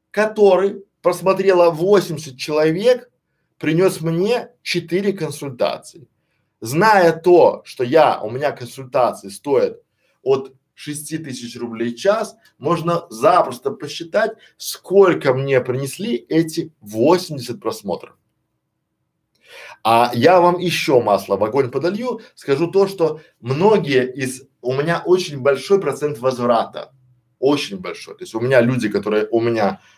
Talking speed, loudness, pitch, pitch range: 120 wpm, -18 LUFS, 160 Hz, 130-195 Hz